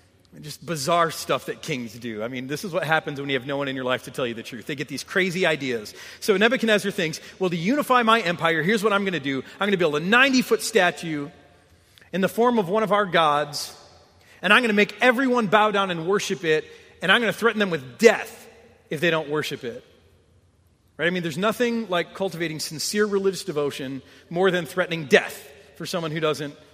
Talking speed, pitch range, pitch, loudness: 225 wpm, 140-205 Hz, 170 Hz, -22 LUFS